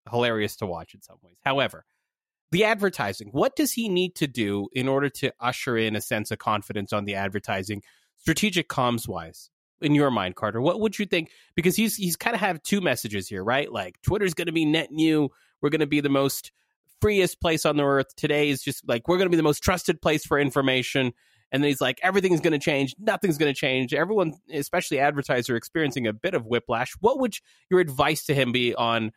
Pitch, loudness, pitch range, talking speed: 145 Hz, -25 LUFS, 115-170 Hz, 210 wpm